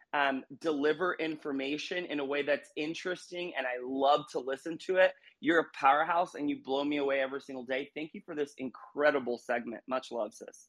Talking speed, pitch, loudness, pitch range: 195 wpm, 145 Hz, -32 LUFS, 135-160 Hz